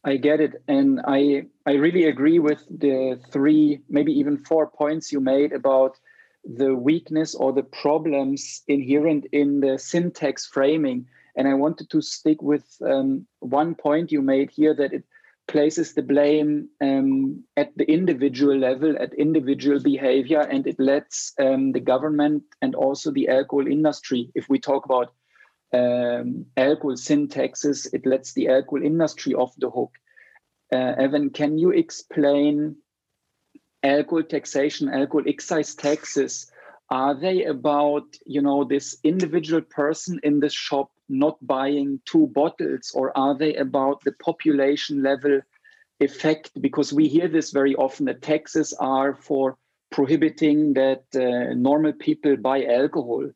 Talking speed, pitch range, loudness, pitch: 145 wpm, 135-155 Hz, -22 LUFS, 145 Hz